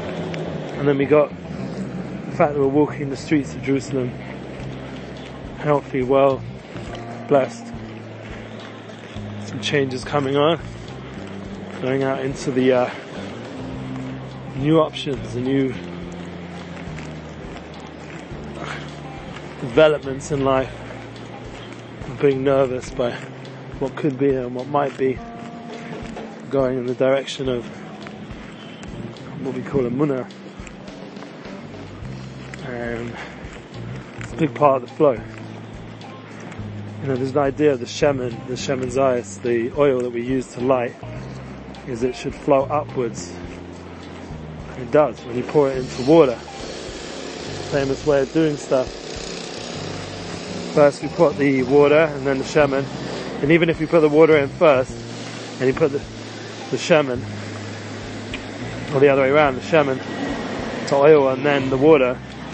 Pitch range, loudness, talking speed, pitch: 110-140 Hz, -20 LUFS, 130 wpm, 130 Hz